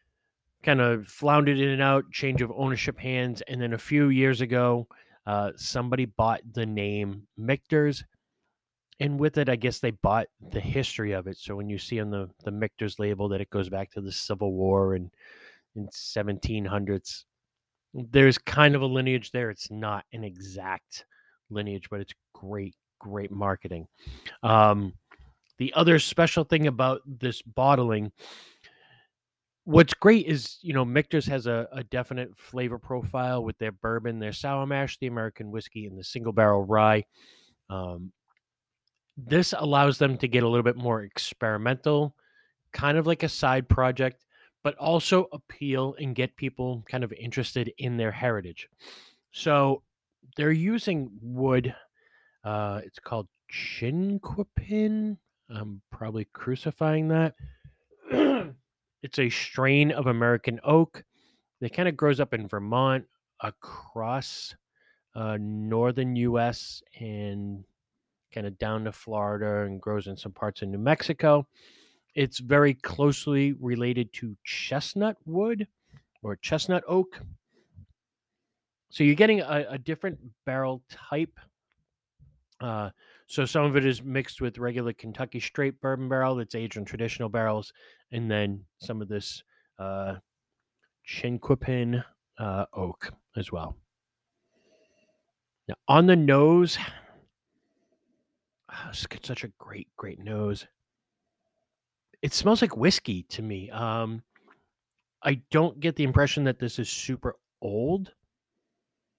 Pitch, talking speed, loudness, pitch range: 125 Hz, 135 wpm, -27 LUFS, 105-145 Hz